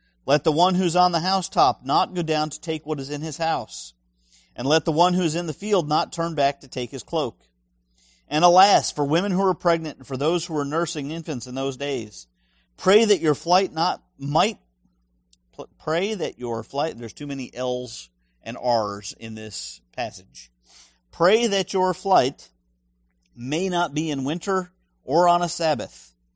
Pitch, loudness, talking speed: 145 Hz, -23 LUFS, 185 wpm